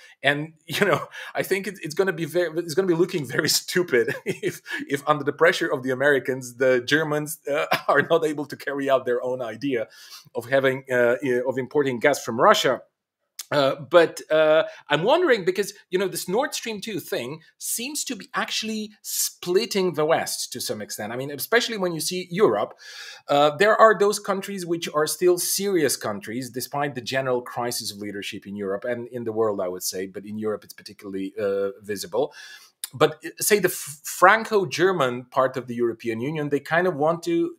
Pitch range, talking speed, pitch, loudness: 125-185 Hz, 195 wpm, 150 Hz, -23 LUFS